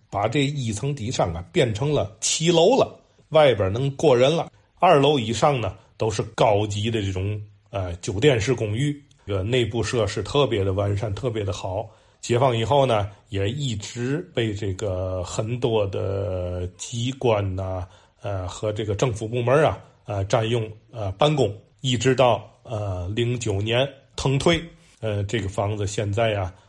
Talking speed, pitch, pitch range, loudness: 230 characters per minute, 110 Hz, 100-130 Hz, -23 LUFS